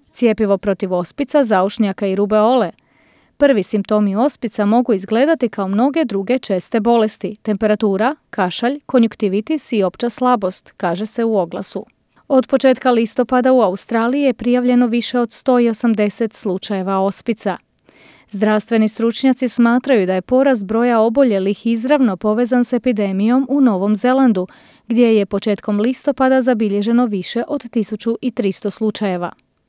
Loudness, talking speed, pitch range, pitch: -16 LUFS, 125 wpm, 205-250 Hz, 230 Hz